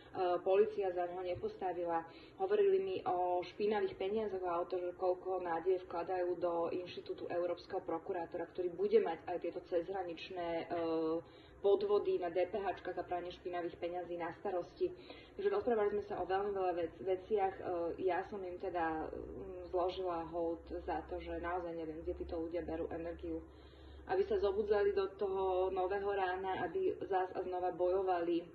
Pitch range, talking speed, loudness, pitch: 175-205 Hz, 150 wpm, -38 LUFS, 180 Hz